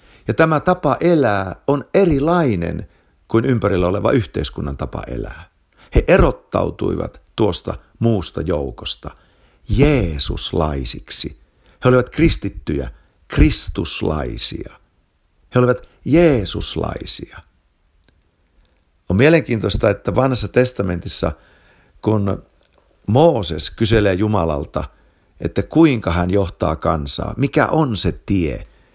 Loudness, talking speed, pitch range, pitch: -18 LUFS, 90 wpm, 85-125 Hz, 100 Hz